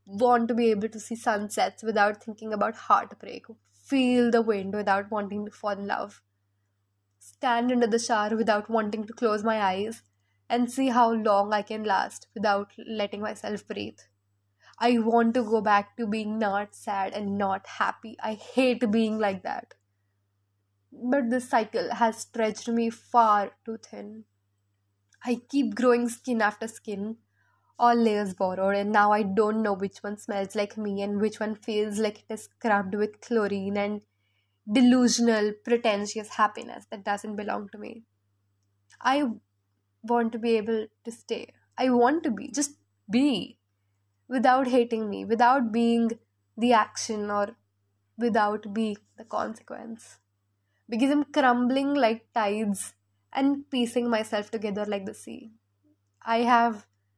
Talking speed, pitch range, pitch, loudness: 150 wpm, 195-235 Hz, 215 Hz, -26 LUFS